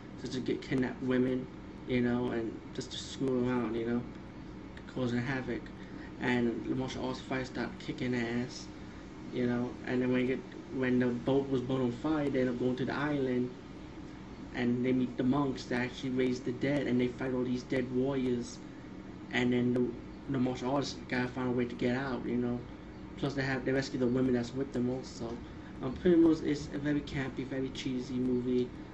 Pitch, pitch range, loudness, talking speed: 125 Hz, 125-130 Hz, -33 LUFS, 205 wpm